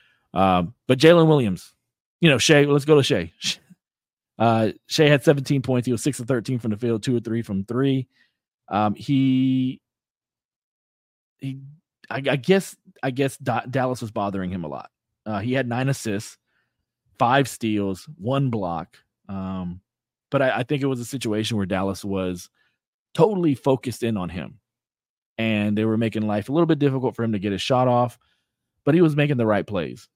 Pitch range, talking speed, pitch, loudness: 105-140 Hz, 185 wpm, 125 Hz, -22 LUFS